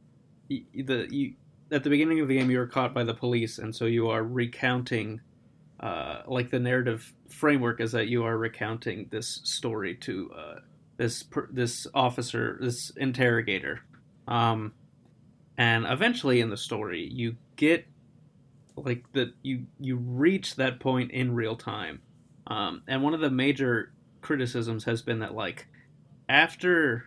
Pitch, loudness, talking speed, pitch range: 125 Hz, -28 LUFS, 150 wpm, 115-140 Hz